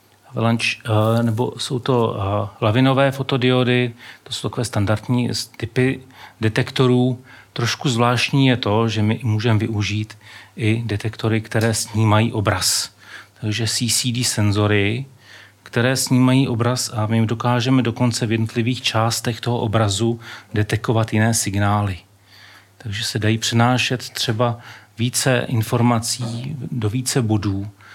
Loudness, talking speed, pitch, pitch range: -19 LUFS, 110 wpm, 115 Hz, 110-125 Hz